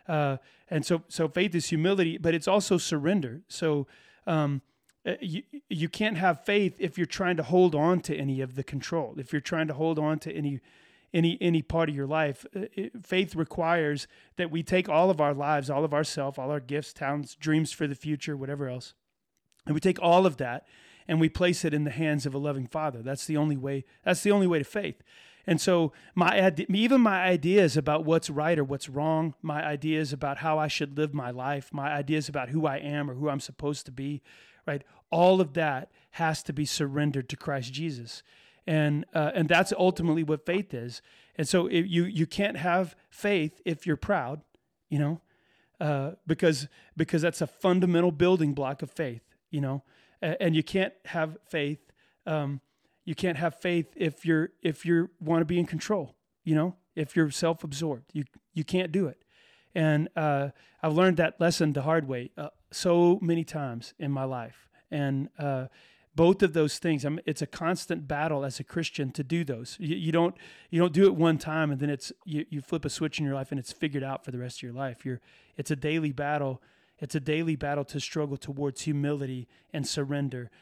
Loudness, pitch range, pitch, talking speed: -28 LUFS, 145-170 Hz, 155 Hz, 210 wpm